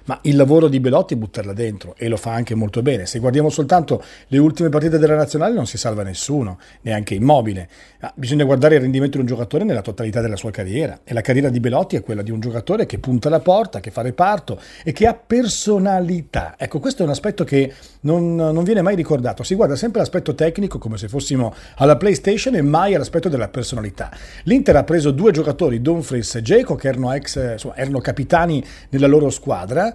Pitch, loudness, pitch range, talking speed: 140 Hz, -18 LUFS, 120-165 Hz, 210 wpm